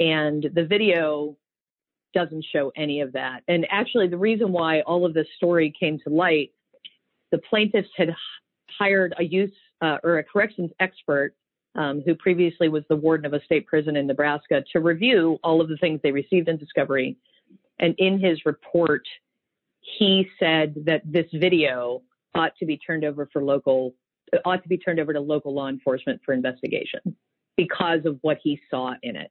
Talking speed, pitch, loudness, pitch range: 180 wpm, 160 Hz, -23 LUFS, 150-180 Hz